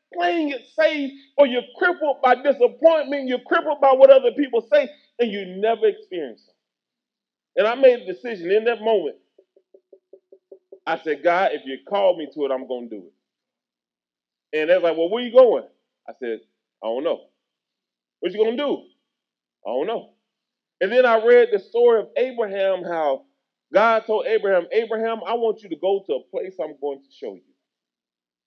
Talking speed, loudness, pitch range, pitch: 190 wpm, -20 LUFS, 190-300 Hz, 240 Hz